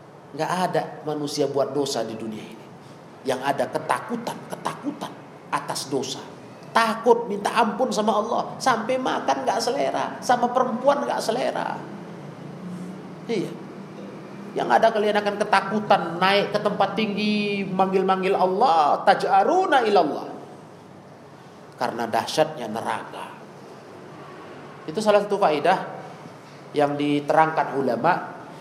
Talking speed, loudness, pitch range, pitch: 105 wpm, -23 LUFS, 160-215 Hz, 195 Hz